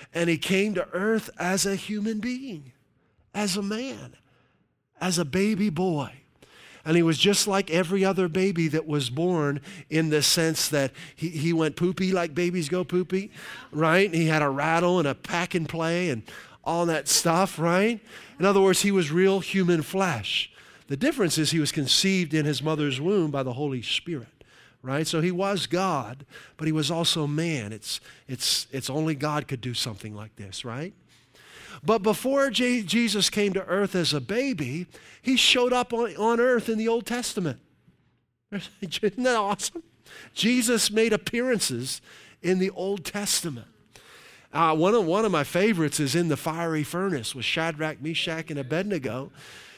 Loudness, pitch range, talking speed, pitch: -25 LUFS, 150-200 Hz, 175 wpm, 170 Hz